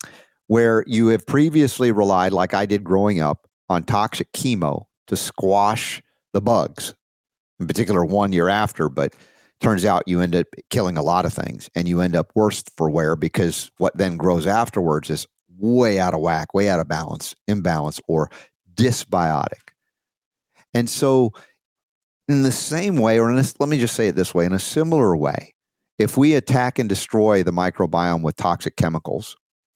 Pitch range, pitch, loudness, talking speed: 90-120 Hz, 100 Hz, -20 LUFS, 175 wpm